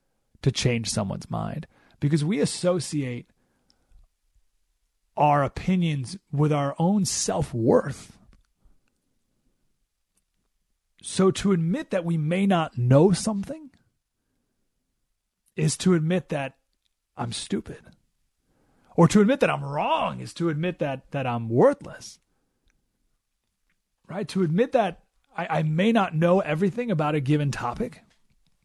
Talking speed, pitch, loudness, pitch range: 115 wpm, 165 Hz, -24 LUFS, 140-185 Hz